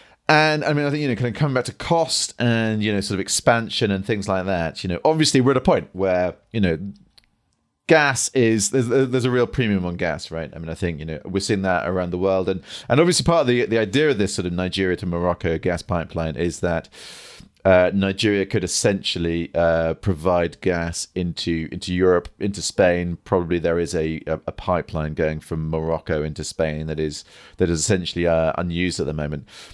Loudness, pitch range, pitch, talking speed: -21 LUFS, 85-110 Hz, 90 Hz, 220 wpm